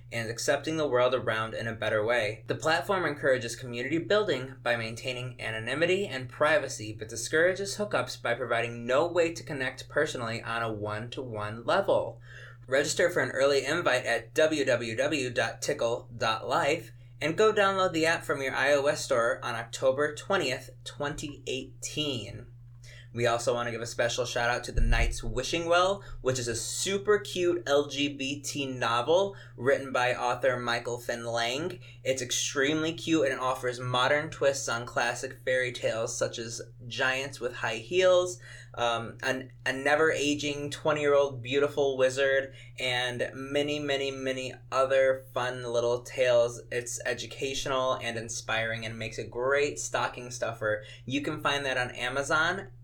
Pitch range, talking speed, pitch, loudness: 120-140 Hz, 150 wpm, 125 Hz, -29 LUFS